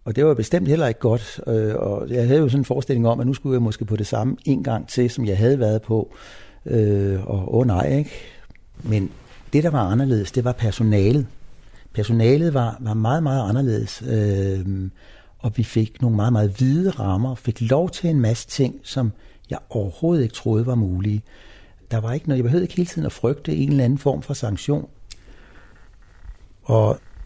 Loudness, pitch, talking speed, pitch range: -21 LUFS, 115 Hz, 195 wpm, 105-135 Hz